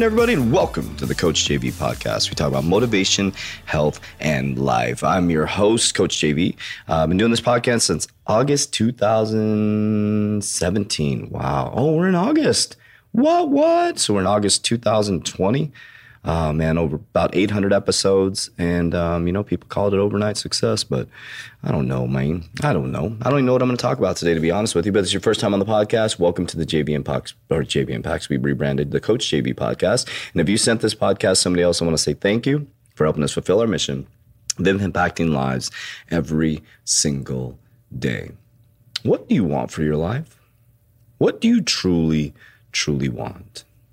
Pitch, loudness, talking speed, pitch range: 100 Hz, -20 LUFS, 195 wpm, 80-115 Hz